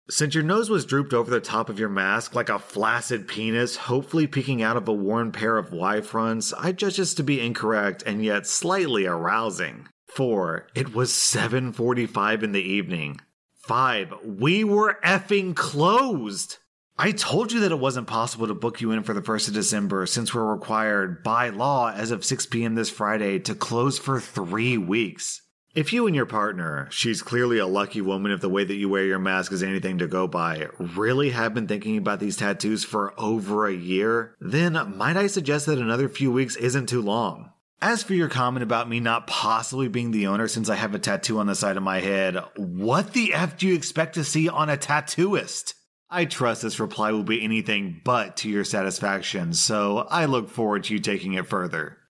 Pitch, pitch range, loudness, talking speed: 115 Hz, 105-145 Hz, -24 LUFS, 205 wpm